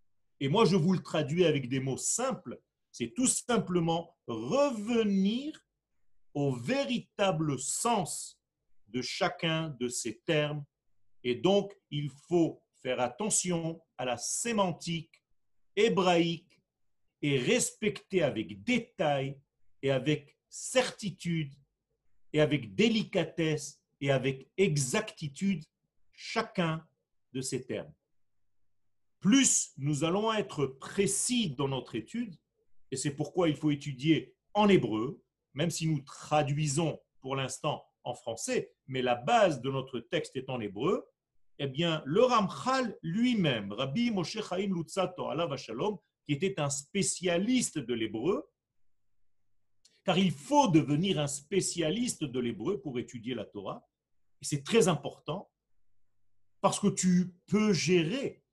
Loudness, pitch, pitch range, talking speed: -31 LUFS, 155 Hz, 130-195 Hz, 125 wpm